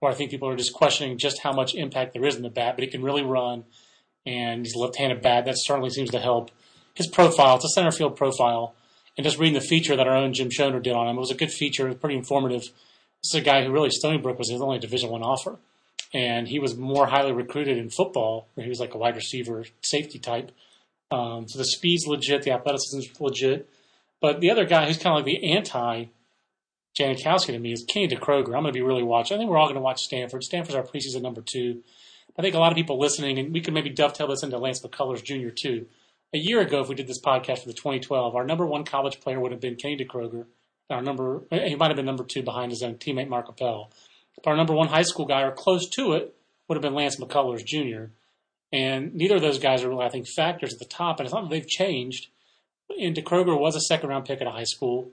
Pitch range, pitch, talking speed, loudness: 125-150 Hz, 135 Hz, 255 wpm, -25 LUFS